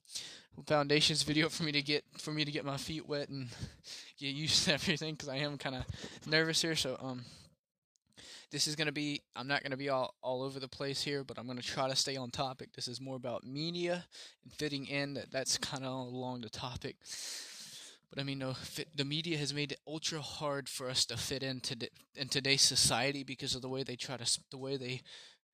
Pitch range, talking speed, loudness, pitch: 130-150 Hz, 235 wpm, -35 LUFS, 140 Hz